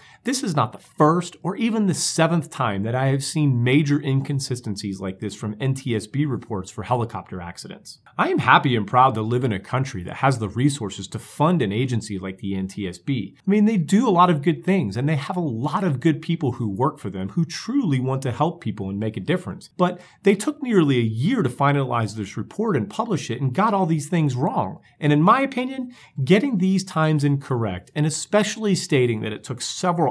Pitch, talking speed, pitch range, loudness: 140 Hz, 220 wpm, 115-175 Hz, -22 LUFS